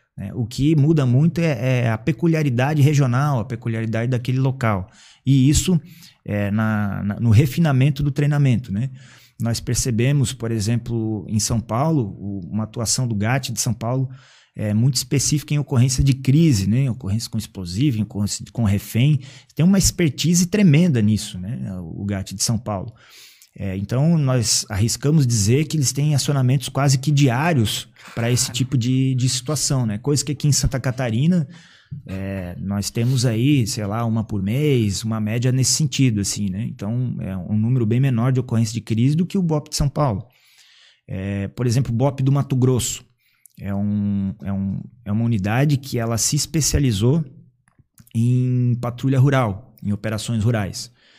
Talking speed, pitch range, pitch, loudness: 175 wpm, 110-140 Hz, 125 Hz, -20 LUFS